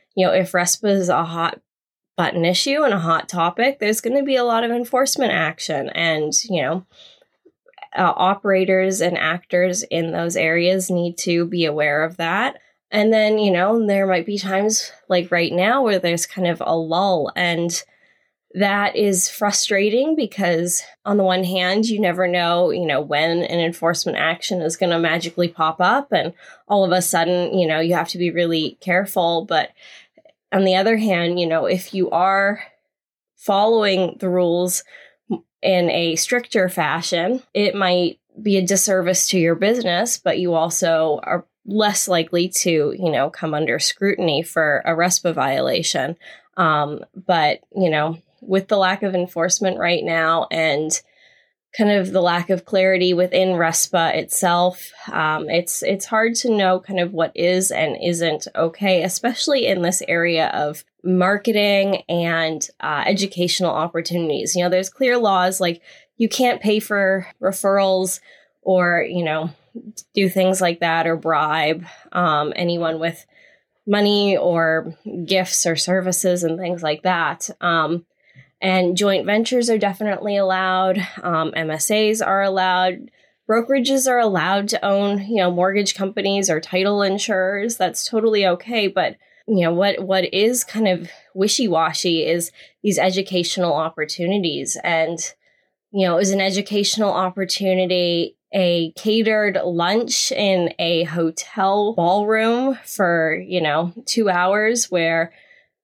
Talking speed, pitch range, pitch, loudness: 155 wpm, 170-200 Hz, 185 Hz, -19 LUFS